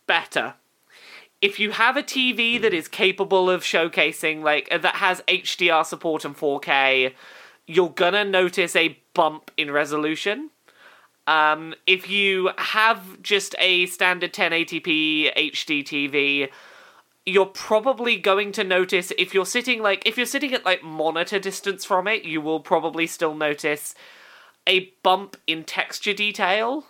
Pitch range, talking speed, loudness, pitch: 160-205 Hz, 145 wpm, -21 LUFS, 185 Hz